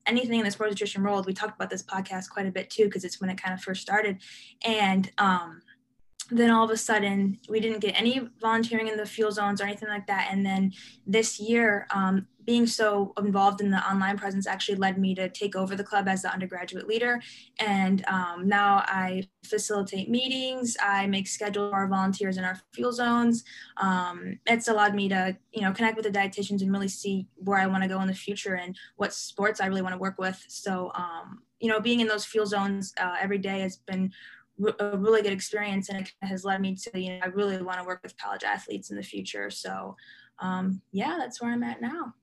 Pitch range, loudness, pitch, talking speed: 190-215 Hz, -28 LUFS, 200 Hz, 225 wpm